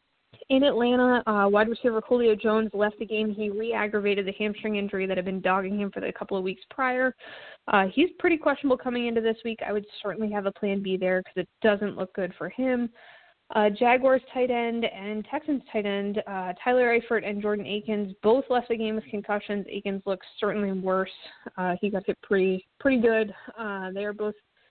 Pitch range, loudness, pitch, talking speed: 200-235 Hz, -26 LUFS, 210 Hz, 205 wpm